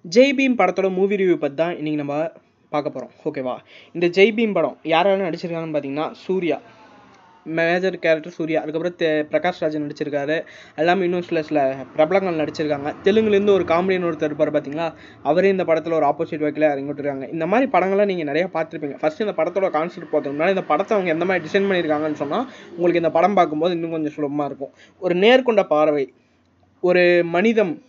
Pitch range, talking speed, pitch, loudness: 150-185 Hz, 165 wpm, 165 Hz, -20 LUFS